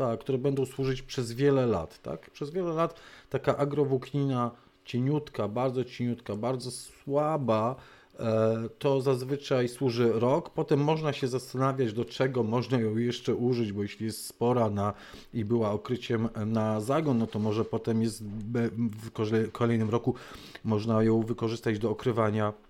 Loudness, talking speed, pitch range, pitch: -29 LUFS, 145 wpm, 110-135 Hz, 120 Hz